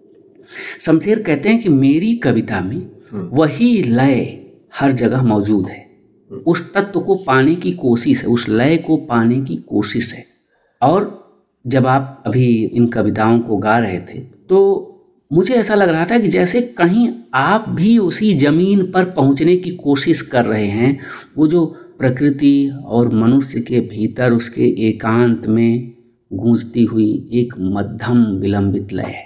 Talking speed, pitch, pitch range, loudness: 150 wpm, 135 Hz, 115-175 Hz, -15 LUFS